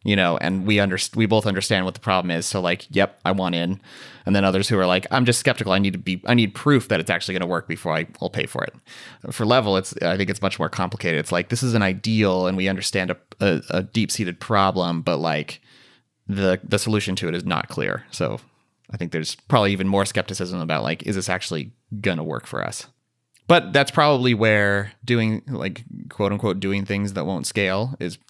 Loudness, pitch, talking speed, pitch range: -22 LUFS, 100 Hz, 235 wpm, 90-110 Hz